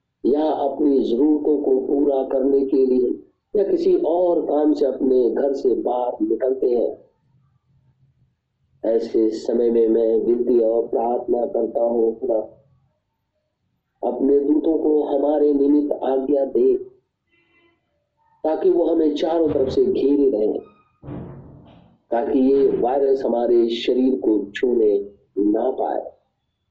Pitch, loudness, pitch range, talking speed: 140 Hz, -20 LUFS, 120-160 Hz, 120 wpm